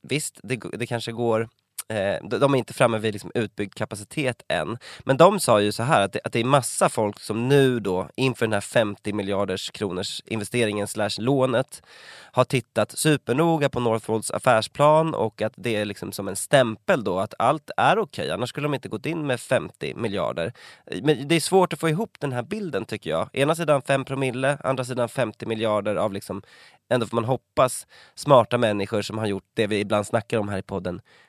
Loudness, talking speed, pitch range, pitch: -24 LUFS, 205 wpm, 105-135 Hz, 115 Hz